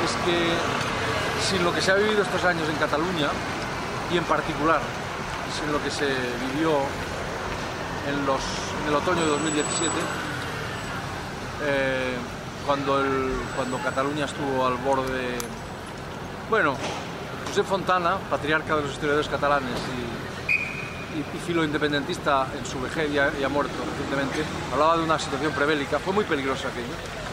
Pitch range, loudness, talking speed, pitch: 135-160 Hz, -25 LUFS, 140 wpm, 145 Hz